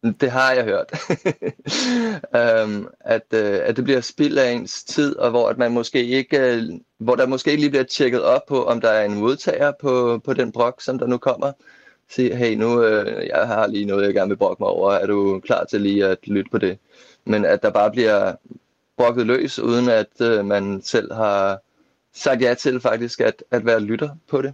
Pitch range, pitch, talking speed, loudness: 110-135 Hz, 120 Hz, 220 wpm, -20 LUFS